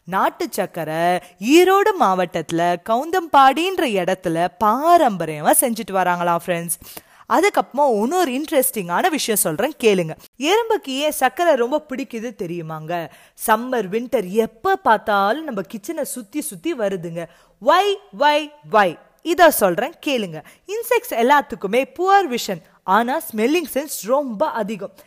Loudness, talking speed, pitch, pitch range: -19 LUFS, 110 wpm, 235 Hz, 190-305 Hz